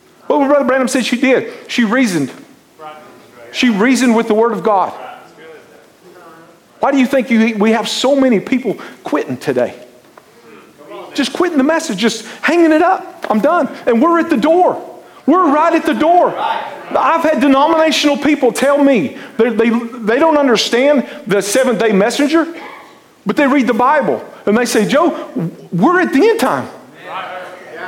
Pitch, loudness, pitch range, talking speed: 270 Hz, -13 LUFS, 230-305 Hz, 165 wpm